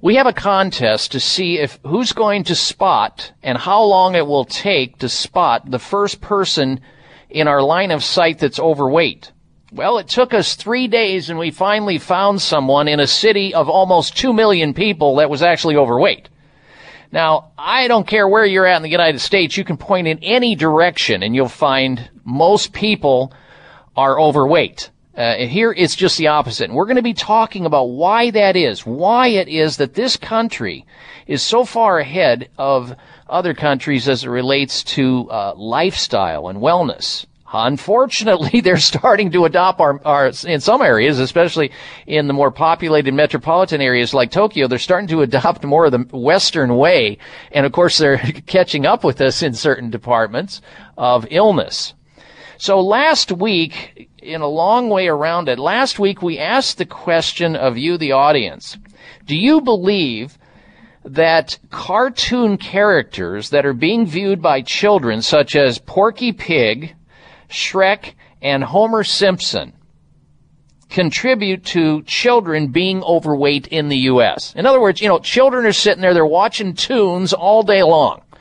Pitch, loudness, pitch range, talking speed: 170 Hz, -15 LUFS, 145-205 Hz, 165 wpm